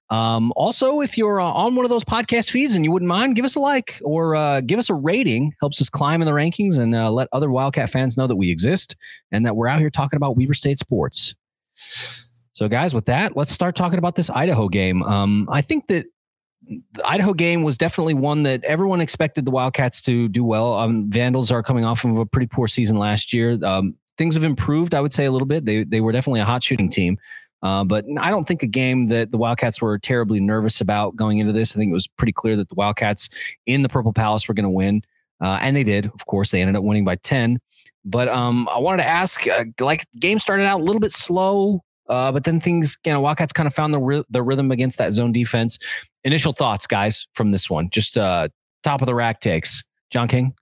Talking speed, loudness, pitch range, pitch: 240 wpm, -19 LUFS, 115-160 Hz, 130 Hz